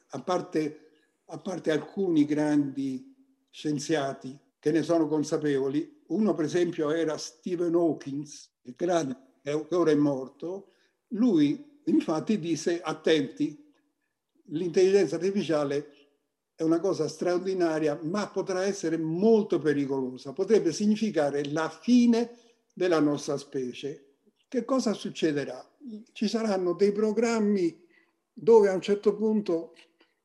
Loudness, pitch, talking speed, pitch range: -27 LUFS, 170 Hz, 110 wpm, 150-220 Hz